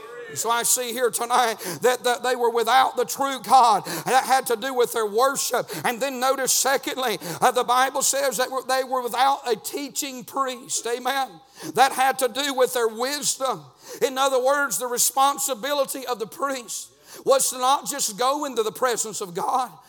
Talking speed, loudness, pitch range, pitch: 180 wpm, -22 LUFS, 245-270 Hz, 255 Hz